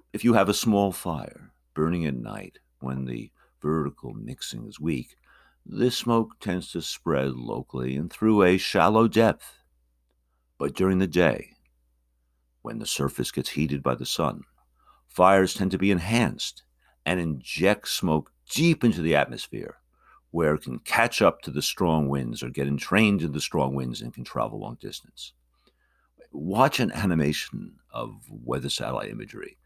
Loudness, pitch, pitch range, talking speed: -25 LUFS, 75 Hz, 60-95 Hz, 160 wpm